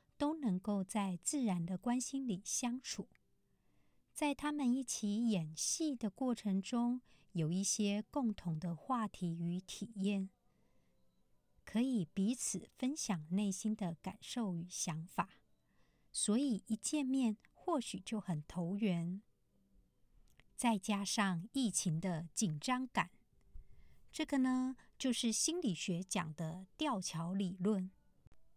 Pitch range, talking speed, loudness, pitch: 185-250 Hz, 170 characters per minute, -39 LUFS, 210 Hz